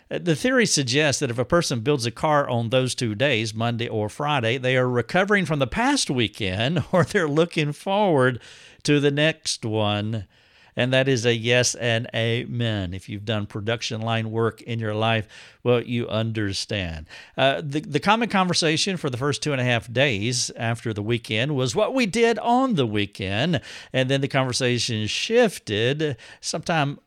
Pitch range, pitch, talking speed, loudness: 115-155 Hz, 125 Hz, 175 wpm, -23 LUFS